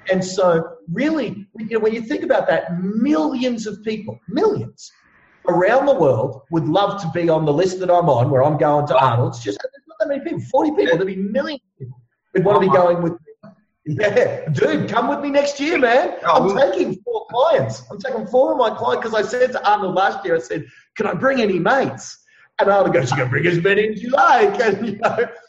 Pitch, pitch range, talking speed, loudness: 205 Hz, 175-265 Hz, 230 wpm, -18 LUFS